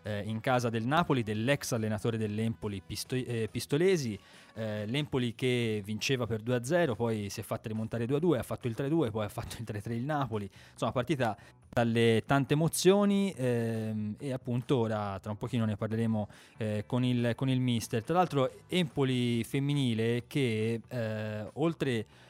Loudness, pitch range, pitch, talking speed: -31 LUFS, 110-135 Hz, 120 Hz, 160 wpm